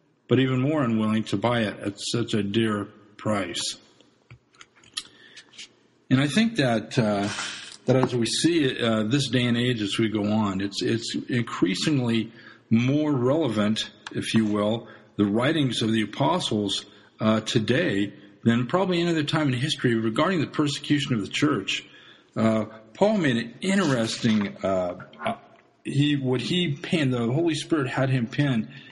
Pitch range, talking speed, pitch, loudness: 110-145 Hz, 155 wpm, 115 Hz, -24 LUFS